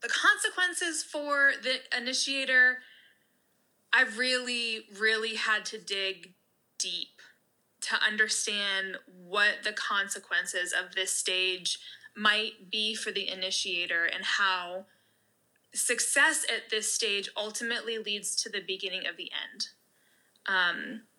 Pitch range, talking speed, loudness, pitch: 190-255 Hz, 115 wpm, -28 LUFS, 215 Hz